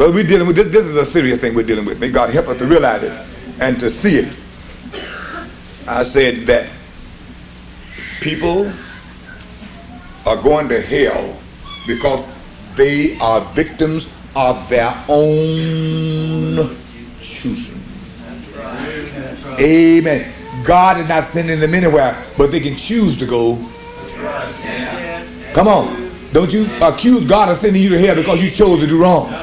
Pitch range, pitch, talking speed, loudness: 125-180 Hz, 160 Hz, 145 wpm, -14 LUFS